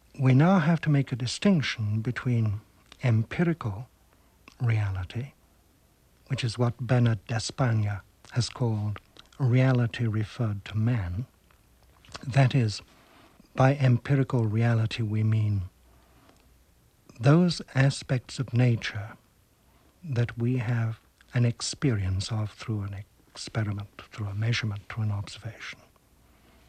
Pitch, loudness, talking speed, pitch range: 115 Hz, -27 LUFS, 105 wpm, 105-130 Hz